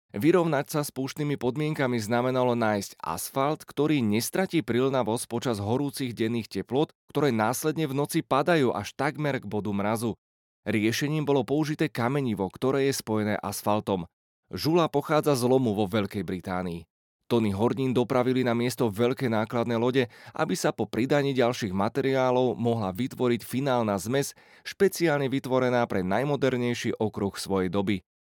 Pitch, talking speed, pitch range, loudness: 125 Hz, 140 wpm, 110-135 Hz, -27 LUFS